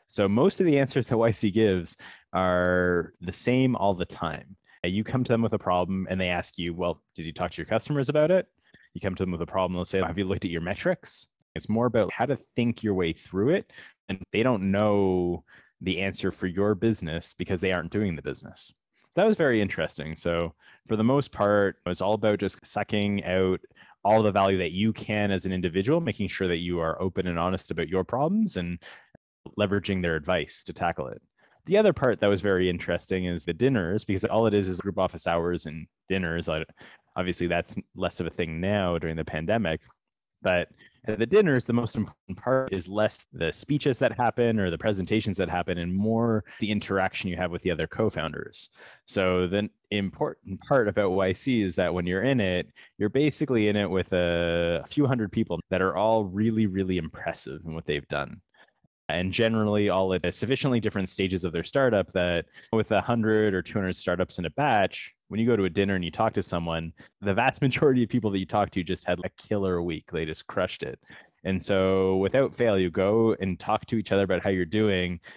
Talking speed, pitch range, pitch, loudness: 220 wpm, 90-110 Hz, 95 Hz, -26 LUFS